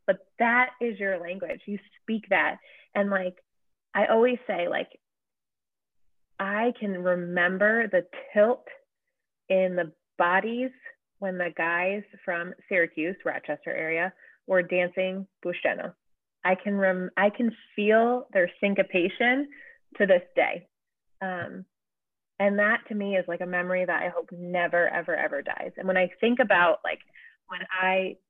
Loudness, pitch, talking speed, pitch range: -26 LUFS, 195 Hz, 140 wpm, 180-230 Hz